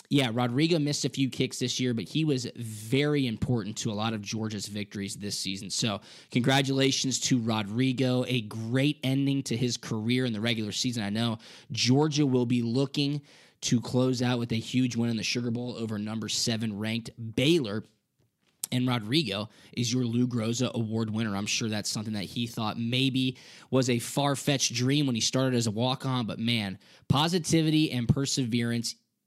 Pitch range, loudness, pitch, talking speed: 115-135 Hz, -28 LUFS, 125 Hz, 180 wpm